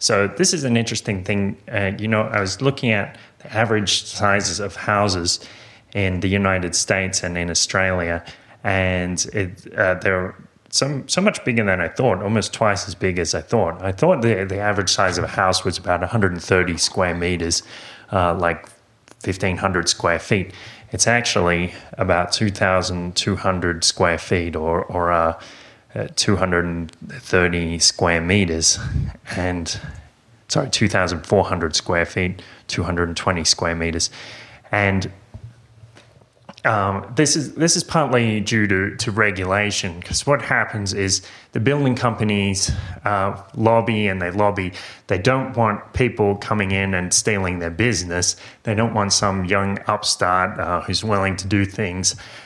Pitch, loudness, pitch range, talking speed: 100 Hz, -20 LUFS, 90-115 Hz, 150 wpm